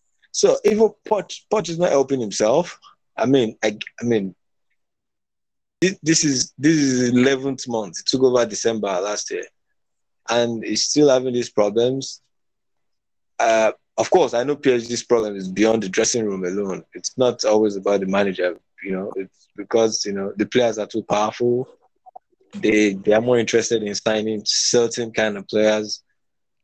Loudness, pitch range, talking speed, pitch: -20 LUFS, 105-130 Hz, 165 wpm, 115 Hz